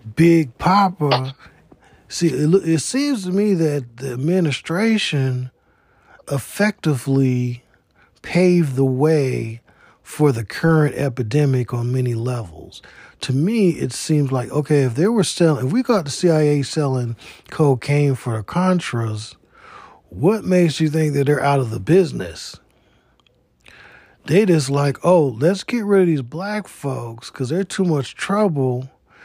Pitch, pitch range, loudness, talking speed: 145 Hz, 130-175 Hz, -19 LUFS, 140 wpm